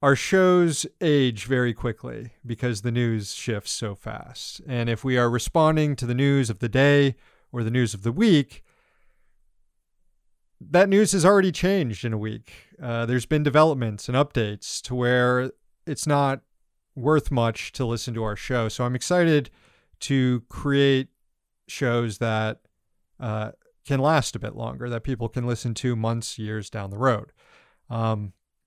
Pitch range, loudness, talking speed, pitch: 115-140 Hz, -23 LUFS, 160 wpm, 125 Hz